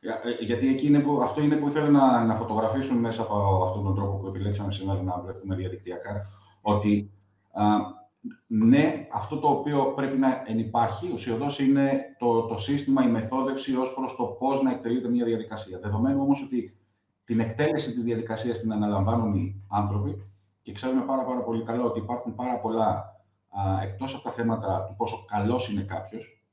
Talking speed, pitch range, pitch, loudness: 170 wpm, 100-130 Hz, 115 Hz, -26 LUFS